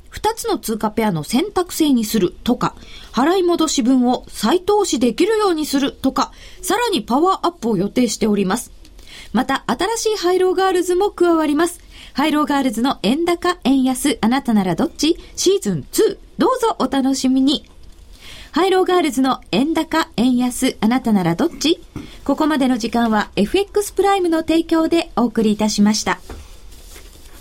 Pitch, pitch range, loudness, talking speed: 275 Hz, 230-355 Hz, -18 LUFS, 335 characters per minute